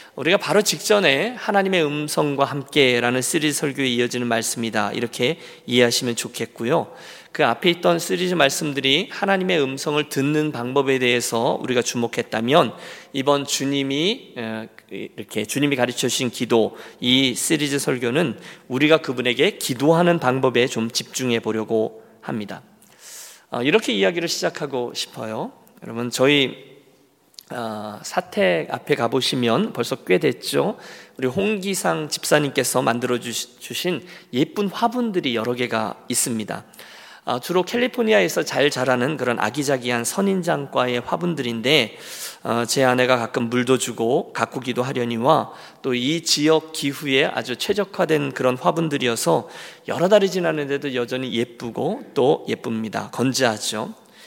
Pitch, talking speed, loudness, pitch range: 135 Hz, 315 characters per minute, -21 LUFS, 120-160 Hz